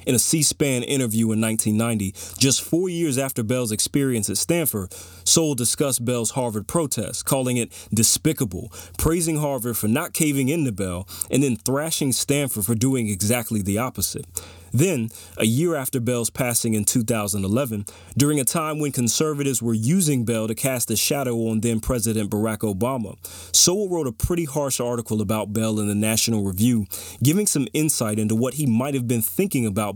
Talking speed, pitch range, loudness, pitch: 175 wpm, 110-140 Hz, -22 LUFS, 120 Hz